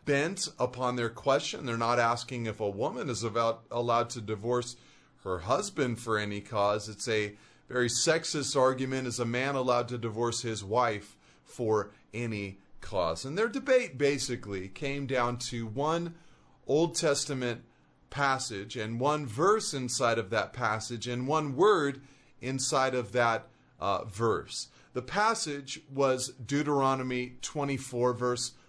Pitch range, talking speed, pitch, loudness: 115-140 Hz, 140 wpm, 125 Hz, -30 LUFS